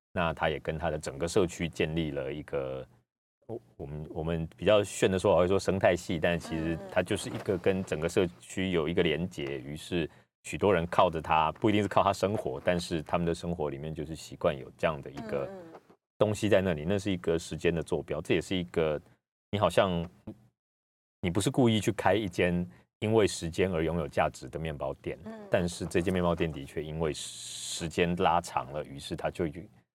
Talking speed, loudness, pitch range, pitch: 300 characters per minute, -30 LUFS, 80-95 Hz, 85 Hz